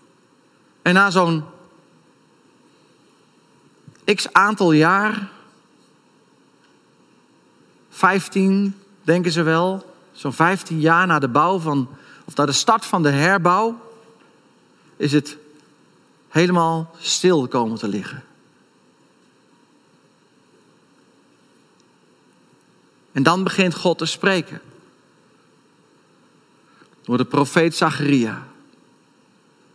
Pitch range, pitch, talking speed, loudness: 150-190 Hz, 170 Hz, 85 wpm, -18 LUFS